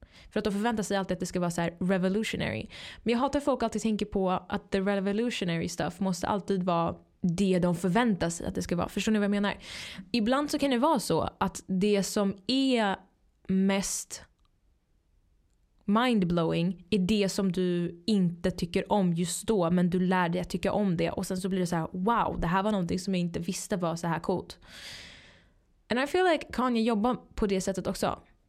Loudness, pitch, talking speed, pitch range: -29 LUFS, 195 Hz, 210 wpm, 180-215 Hz